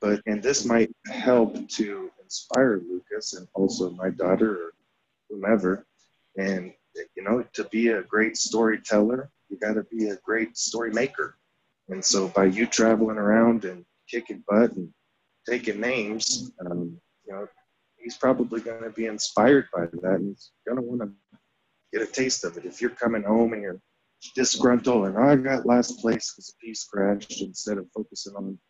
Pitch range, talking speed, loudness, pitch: 100-120 Hz, 170 wpm, -25 LUFS, 110 Hz